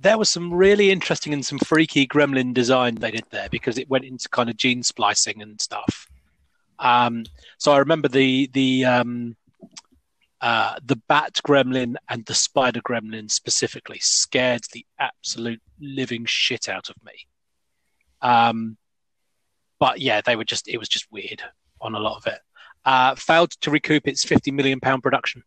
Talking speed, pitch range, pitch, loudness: 165 wpm, 120-140 Hz, 130 Hz, -21 LUFS